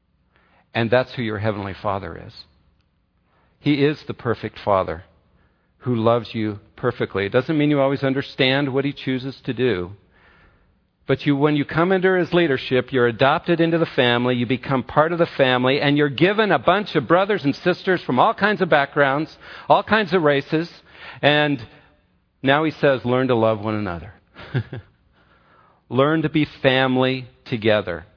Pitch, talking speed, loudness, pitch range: 130 Hz, 165 wpm, -20 LUFS, 110-150 Hz